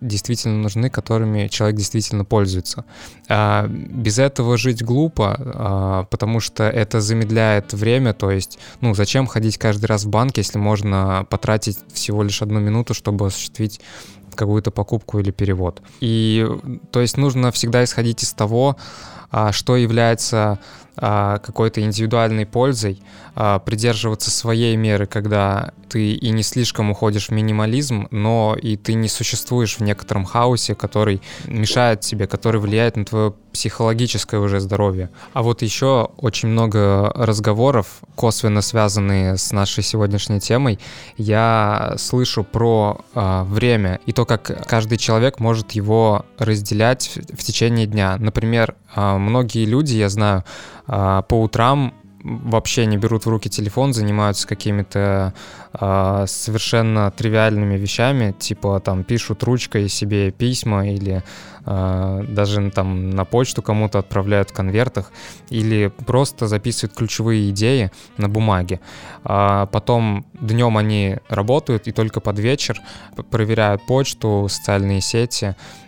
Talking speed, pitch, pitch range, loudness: 130 wpm, 110 Hz, 100-115 Hz, -19 LUFS